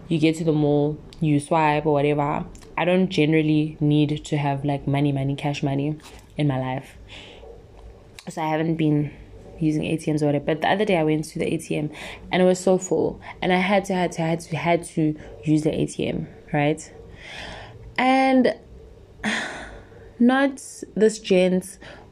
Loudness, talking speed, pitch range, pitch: -22 LUFS, 170 wpm, 145-170 Hz, 155 Hz